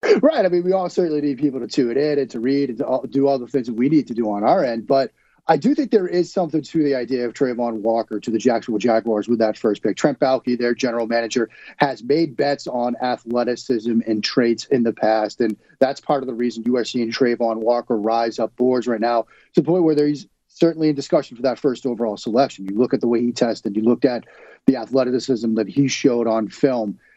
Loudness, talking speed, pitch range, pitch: -20 LUFS, 245 wpm, 115-140 Hz, 125 Hz